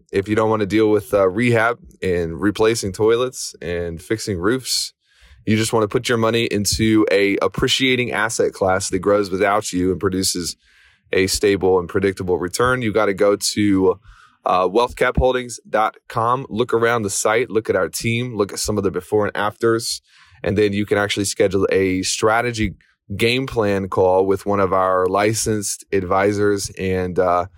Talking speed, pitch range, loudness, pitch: 175 wpm, 95-115 Hz, -19 LUFS, 105 Hz